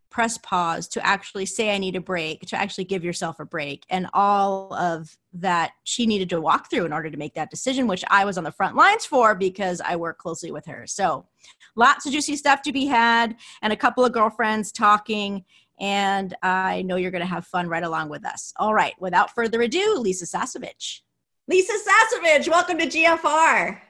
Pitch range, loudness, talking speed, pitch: 180-250 Hz, -22 LUFS, 205 wpm, 200 Hz